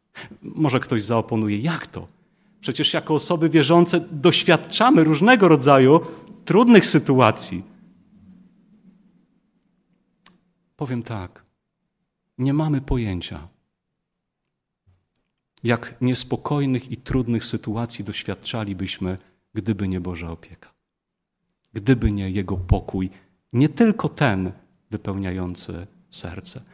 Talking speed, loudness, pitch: 85 wpm, -20 LUFS, 130 Hz